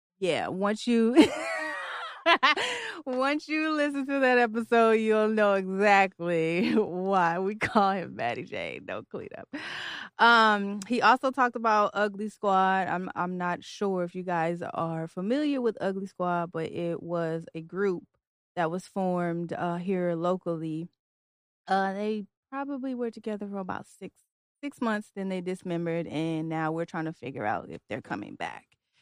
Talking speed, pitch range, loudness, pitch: 155 wpm, 170-225 Hz, -28 LUFS, 195 Hz